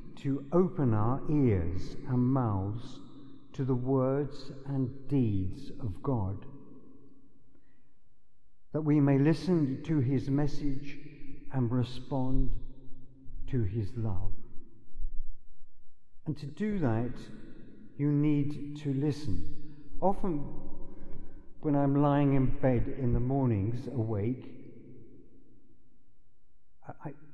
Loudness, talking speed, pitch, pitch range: -31 LUFS, 100 wpm, 135 Hz, 125-145 Hz